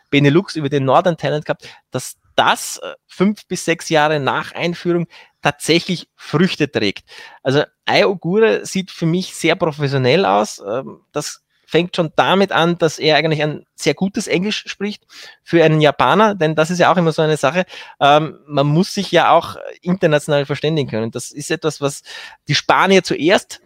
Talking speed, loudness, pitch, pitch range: 165 wpm, -17 LUFS, 160 Hz, 145-180 Hz